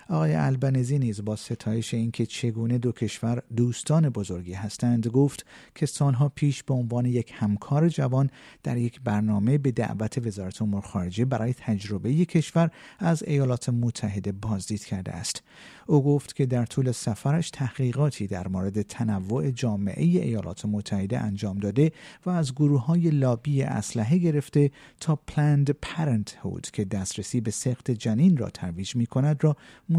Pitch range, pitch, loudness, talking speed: 105-145 Hz, 120 Hz, -26 LUFS, 150 wpm